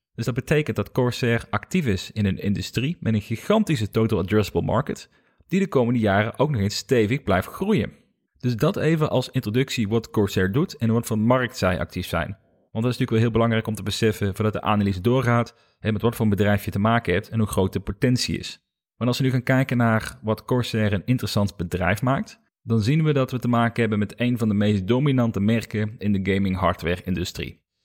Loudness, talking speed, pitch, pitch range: -23 LUFS, 220 wpm, 110 Hz, 105-125 Hz